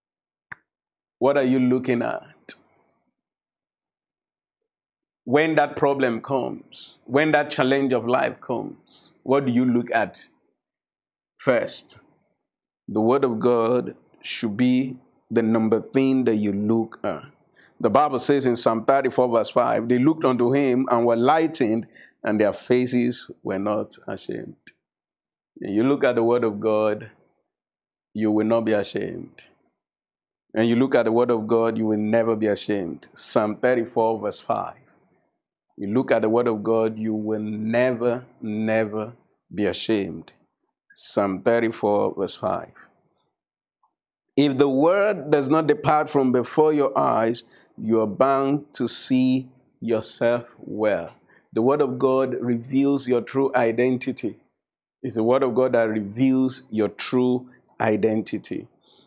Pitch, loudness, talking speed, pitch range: 120 Hz, -22 LUFS, 140 wpm, 115-130 Hz